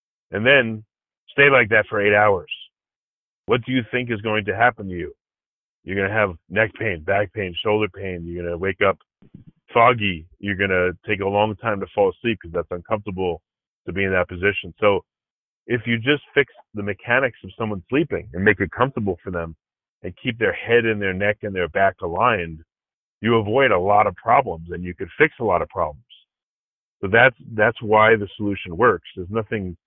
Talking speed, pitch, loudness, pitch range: 200 wpm, 105 Hz, -20 LUFS, 90-115 Hz